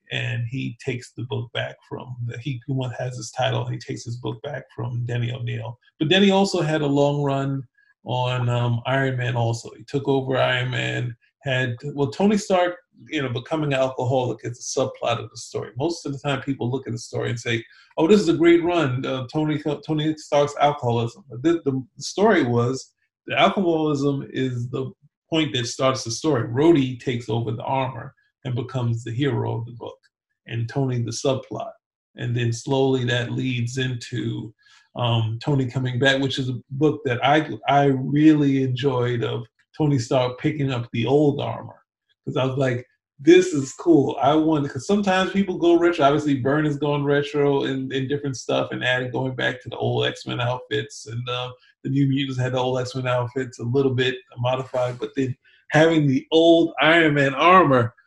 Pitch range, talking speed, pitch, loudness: 120-145 Hz, 190 wpm, 130 Hz, -22 LUFS